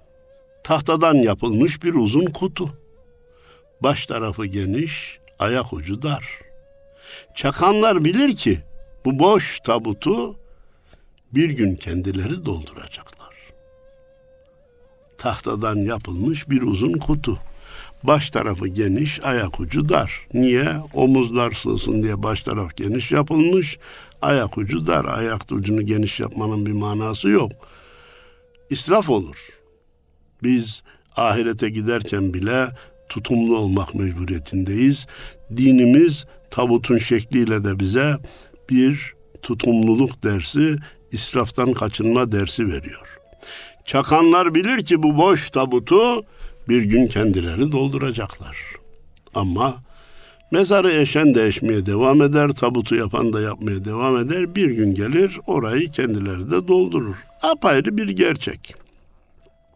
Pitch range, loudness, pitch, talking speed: 105-155 Hz, -19 LUFS, 125 Hz, 105 wpm